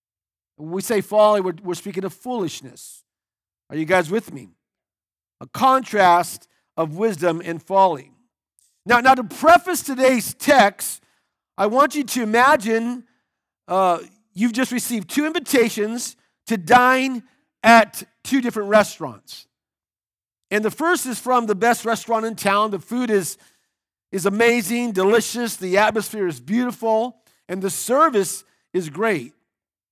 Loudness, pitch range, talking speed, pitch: -19 LUFS, 180-240 Hz, 135 wpm, 215 Hz